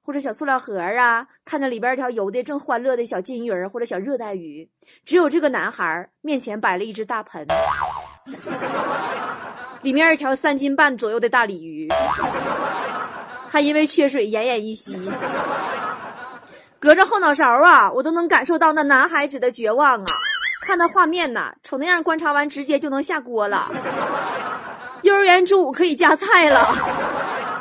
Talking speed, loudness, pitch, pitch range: 250 characters per minute, -19 LUFS, 275 Hz, 235-310 Hz